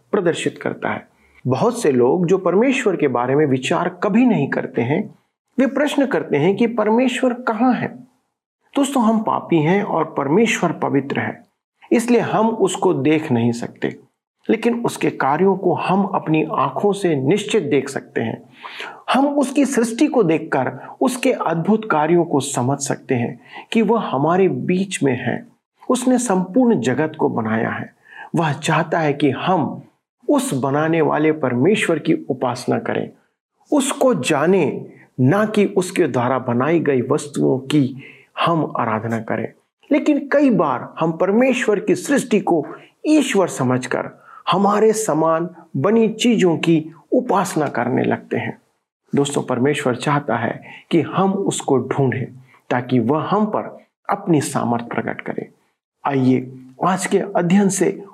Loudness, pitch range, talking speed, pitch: -18 LUFS, 140-220 Hz, 145 wpm, 175 Hz